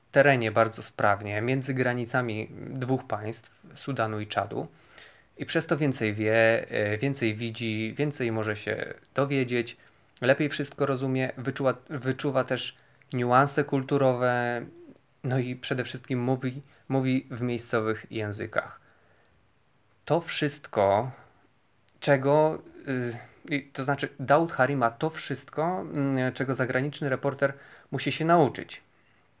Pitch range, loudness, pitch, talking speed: 115-140 Hz, -28 LUFS, 130 Hz, 110 wpm